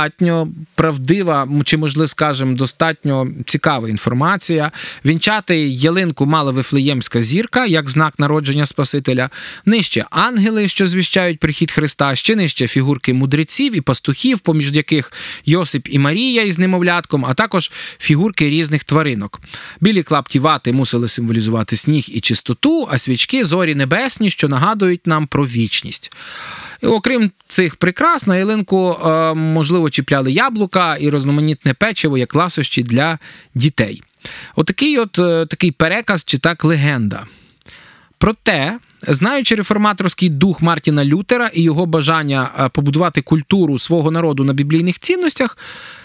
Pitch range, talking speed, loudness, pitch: 140-180 Hz, 120 wpm, -14 LUFS, 160 Hz